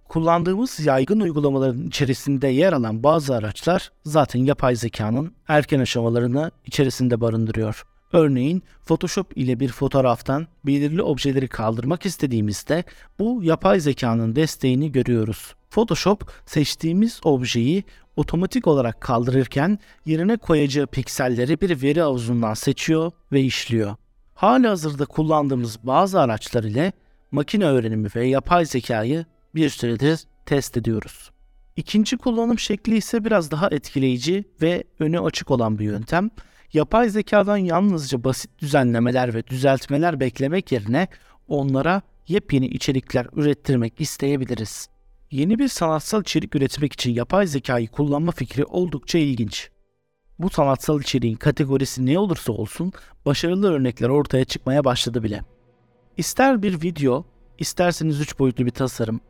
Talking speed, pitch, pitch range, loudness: 120 wpm, 140 Hz, 125-170 Hz, -21 LUFS